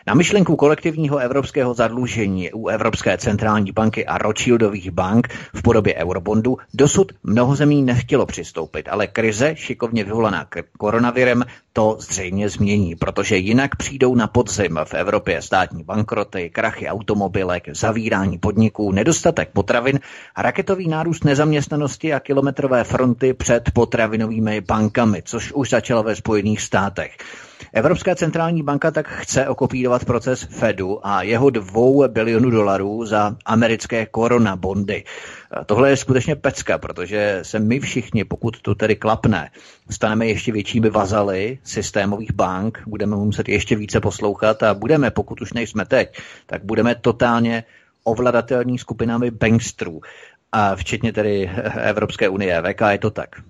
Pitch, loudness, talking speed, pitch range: 115 Hz, -19 LUFS, 135 wpm, 105-125 Hz